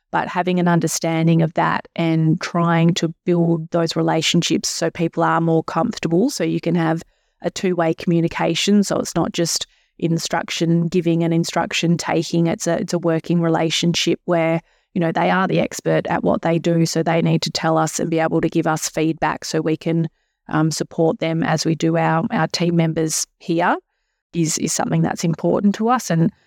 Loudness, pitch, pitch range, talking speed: -19 LUFS, 165 Hz, 165-170 Hz, 195 wpm